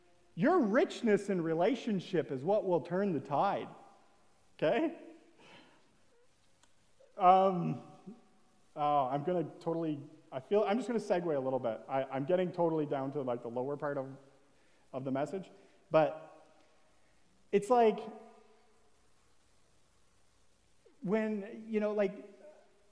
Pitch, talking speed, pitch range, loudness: 190 Hz, 120 wpm, 150-215 Hz, -33 LUFS